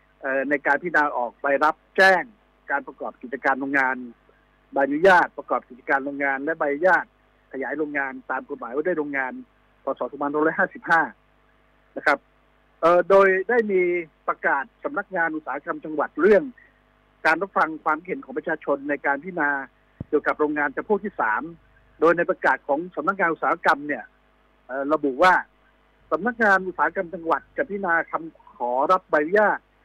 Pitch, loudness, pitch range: 155 Hz, -23 LUFS, 140-185 Hz